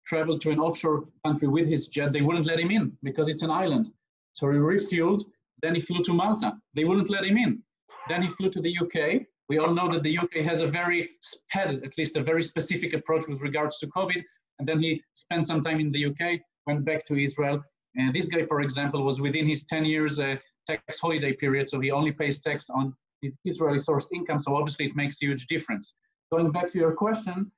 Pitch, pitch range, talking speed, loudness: 160 Hz, 145-175 Hz, 230 wpm, -27 LUFS